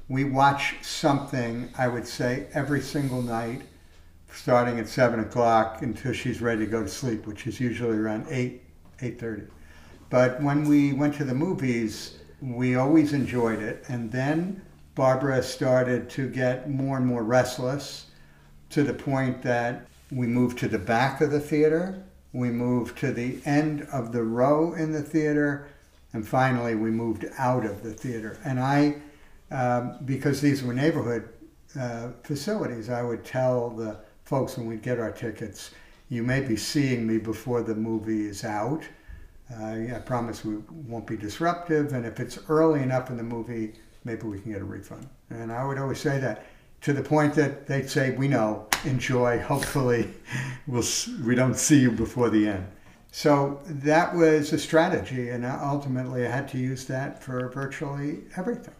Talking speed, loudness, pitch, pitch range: 170 wpm, -26 LUFS, 125 Hz, 115-140 Hz